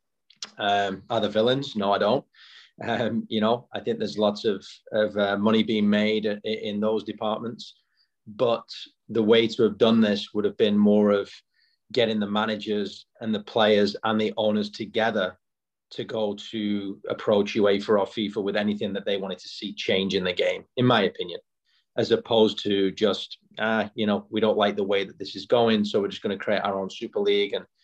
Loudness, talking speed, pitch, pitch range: -25 LUFS, 200 wpm, 105 Hz, 105-110 Hz